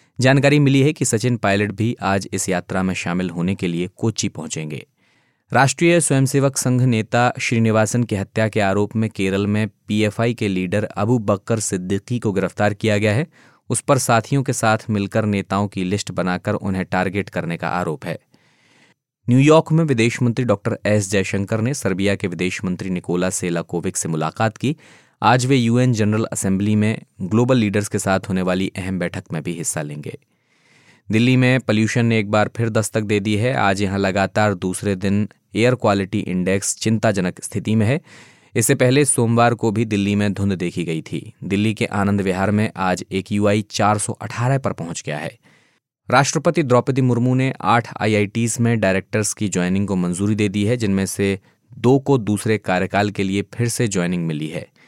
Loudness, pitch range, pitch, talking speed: -19 LUFS, 95-120 Hz, 105 Hz, 185 wpm